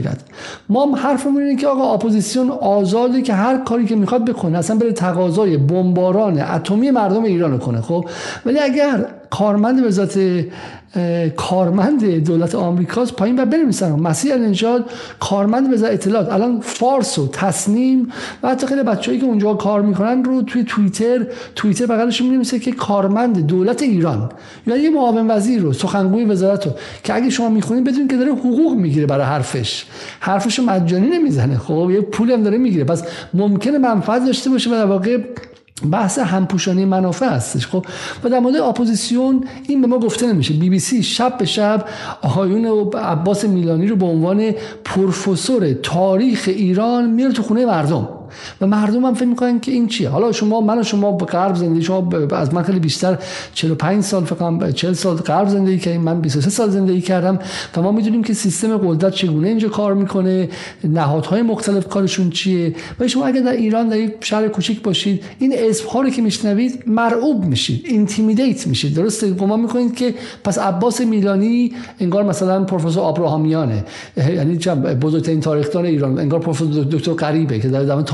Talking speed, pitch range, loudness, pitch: 170 wpm, 175-235 Hz, -16 LUFS, 205 Hz